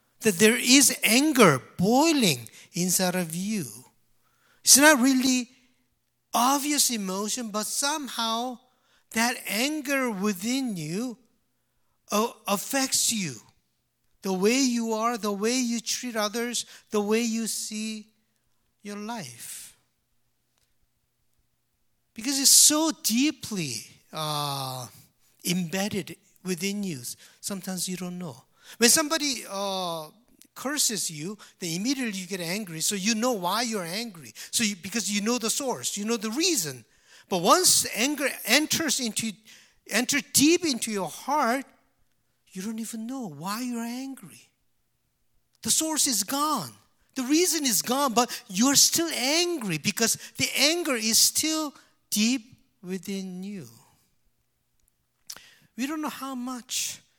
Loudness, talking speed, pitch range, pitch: -24 LUFS, 125 wpm, 195-260 Hz, 225 Hz